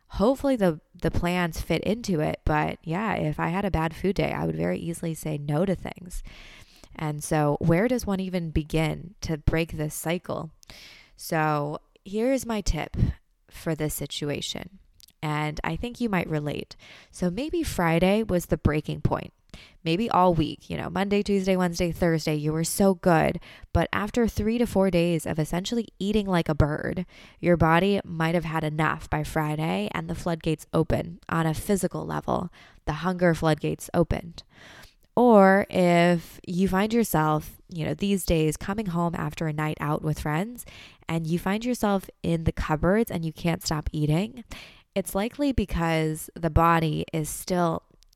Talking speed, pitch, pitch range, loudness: 170 wpm, 170 Hz, 155-190 Hz, -26 LUFS